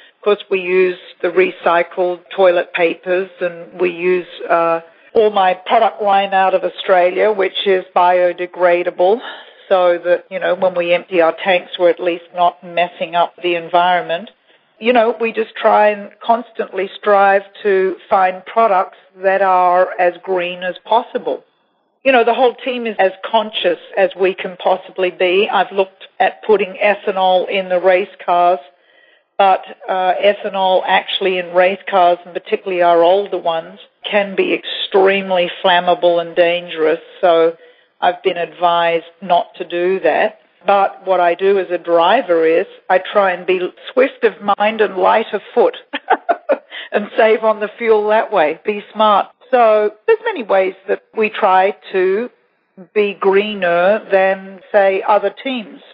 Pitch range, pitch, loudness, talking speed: 180-215 Hz, 190 Hz, -15 LUFS, 155 wpm